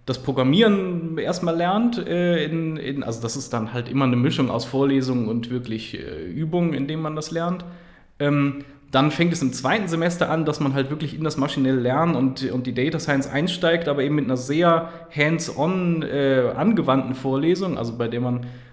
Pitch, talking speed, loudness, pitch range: 145 Hz, 195 wpm, -22 LUFS, 130-165 Hz